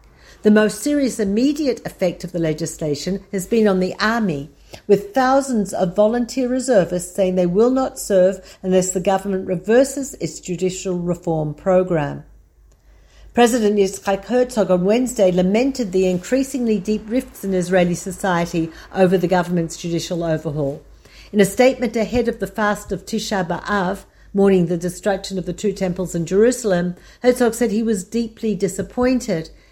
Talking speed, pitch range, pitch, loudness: 150 wpm, 180-225 Hz, 195 Hz, -19 LUFS